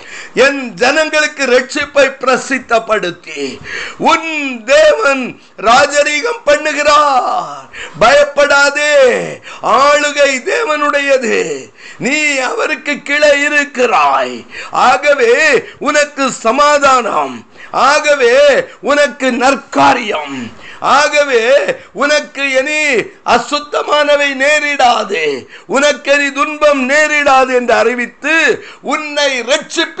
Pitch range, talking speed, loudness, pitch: 260-300 Hz, 70 wpm, -11 LUFS, 290 Hz